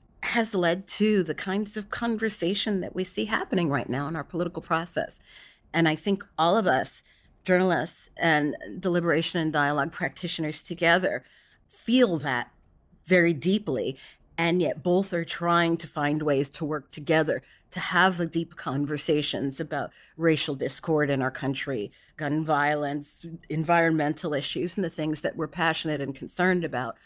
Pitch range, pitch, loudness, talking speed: 150-180 Hz, 165 Hz, -26 LUFS, 155 wpm